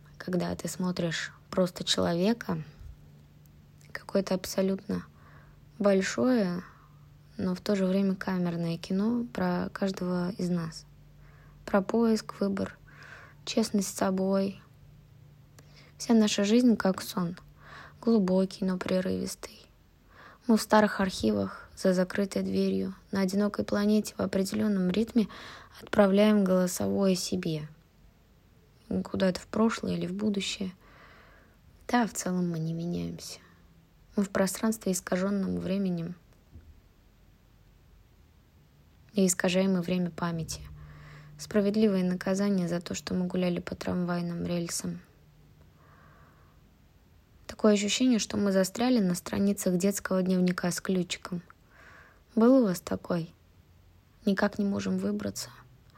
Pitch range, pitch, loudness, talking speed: 140-200 Hz, 180 Hz, -29 LUFS, 105 wpm